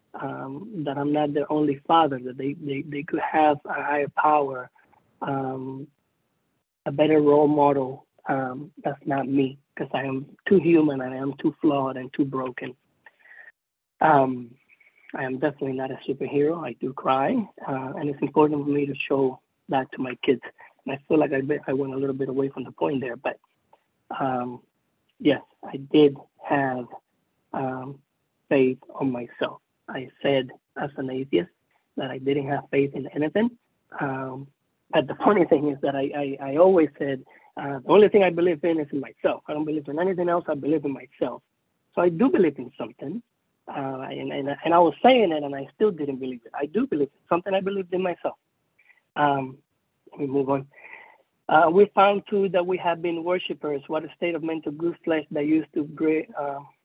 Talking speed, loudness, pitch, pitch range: 195 wpm, -24 LUFS, 145 Hz, 135-160 Hz